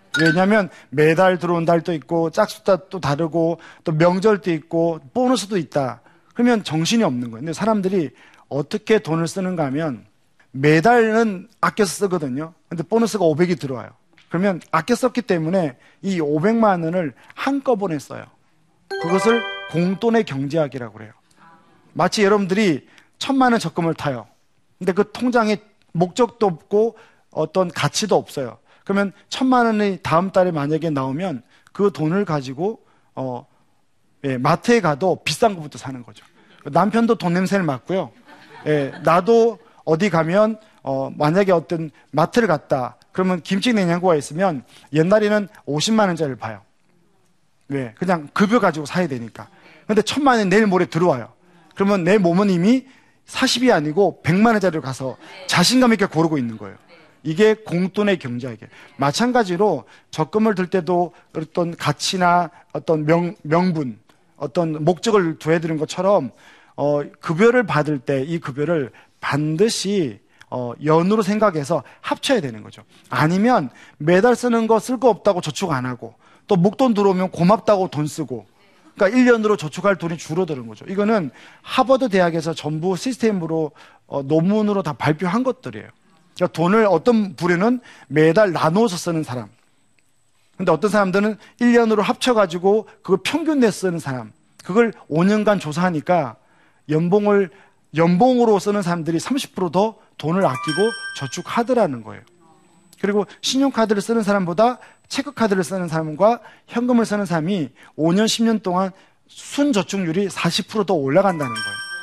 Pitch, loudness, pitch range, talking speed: 180 Hz, -19 LUFS, 155-215 Hz, 315 characters per minute